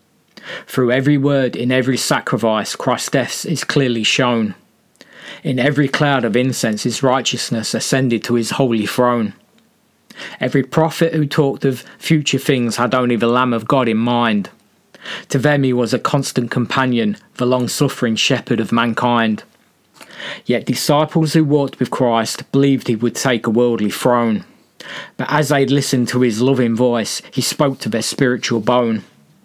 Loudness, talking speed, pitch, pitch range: -17 LUFS, 160 wpm, 125 Hz, 120-140 Hz